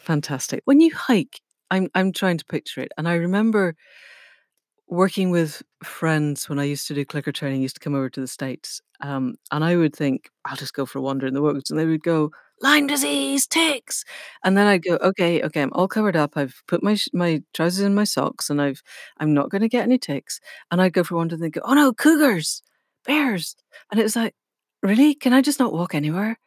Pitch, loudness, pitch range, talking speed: 175 Hz, -21 LUFS, 150-215 Hz, 230 wpm